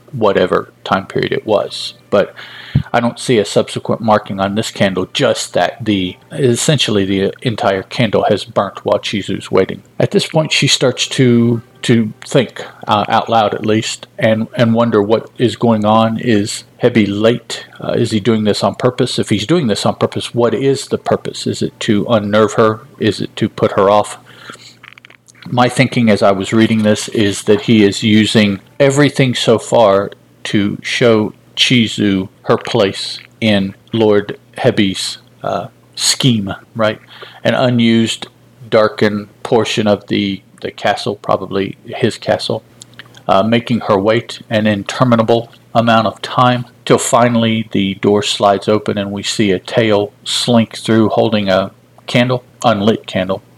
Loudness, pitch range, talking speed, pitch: -14 LUFS, 105-120 Hz, 160 wpm, 110 Hz